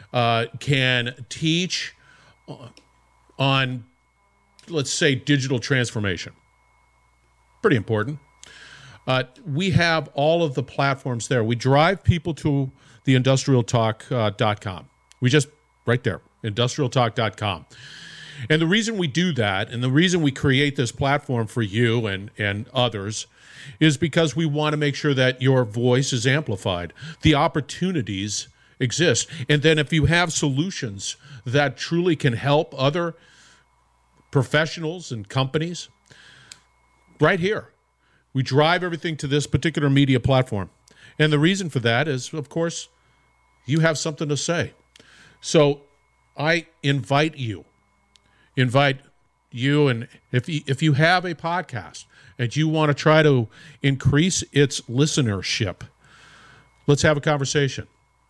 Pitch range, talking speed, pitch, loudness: 120-155 Hz, 130 wpm, 140 Hz, -22 LUFS